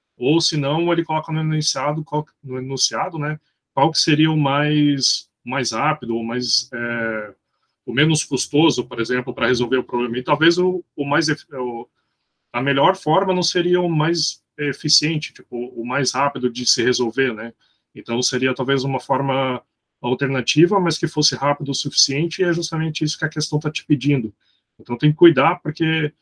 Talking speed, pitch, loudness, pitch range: 180 wpm, 145 Hz, -19 LUFS, 125-155 Hz